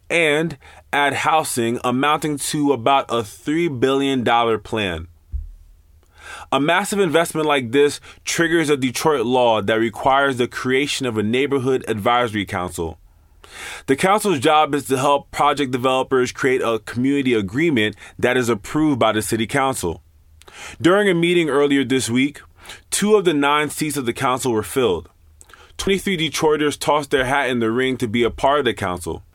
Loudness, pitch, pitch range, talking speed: -19 LUFS, 130 Hz, 110-145 Hz, 160 wpm